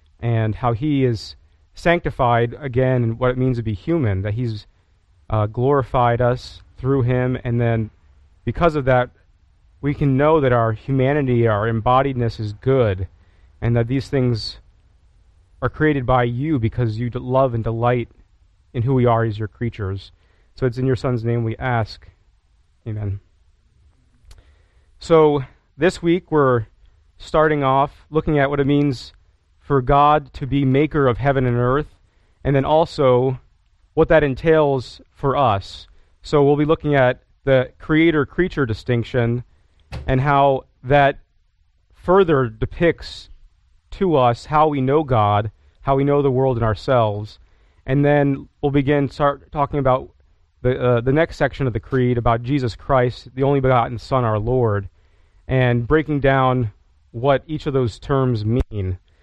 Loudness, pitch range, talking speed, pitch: -19 LUFS, 100-140 Hz, 155 wpm, 125 Hz